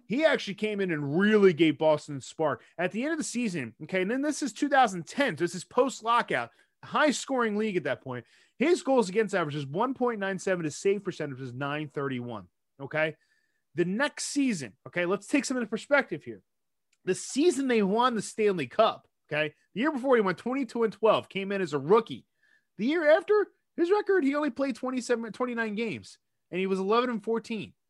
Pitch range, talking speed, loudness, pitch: 170-260 Hz, 195 wpm, -28 LUFS, 215 Hz